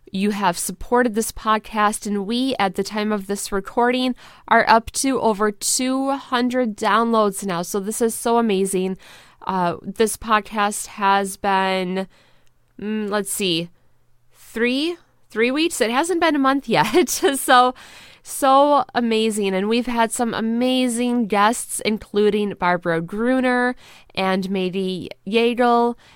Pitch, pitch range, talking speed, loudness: 215 Hz, 195-245 Hz, 135 wpm, -20 LUFS